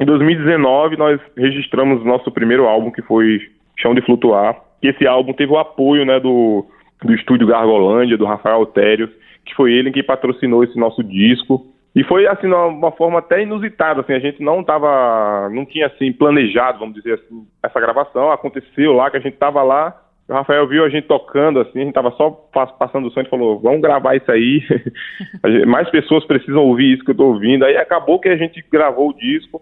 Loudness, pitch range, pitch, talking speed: -14 LUFS, 120-150 Hz, 135 Hz, 205 wpm